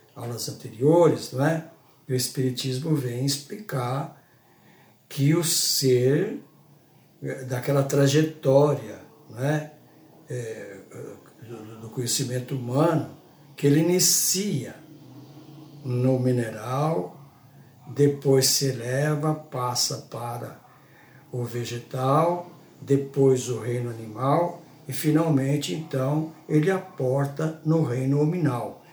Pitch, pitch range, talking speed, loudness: 140 Hz, 130-155 Hz, 85 wpm, -24 LUFS